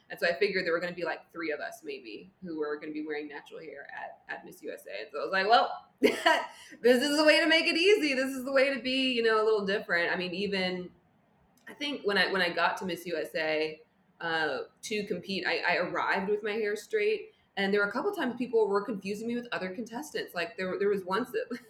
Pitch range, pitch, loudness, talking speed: 185-285 Hz, 215 Hz, -29 LUFS, 255 wpm